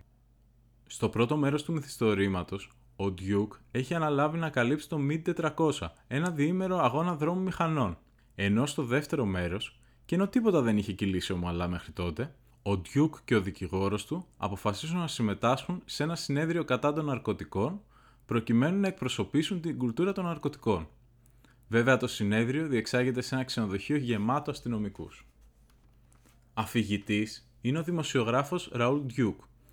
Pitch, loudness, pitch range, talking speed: 120 Hz, -30 LUFS, 105-150 Hz, 140 wpm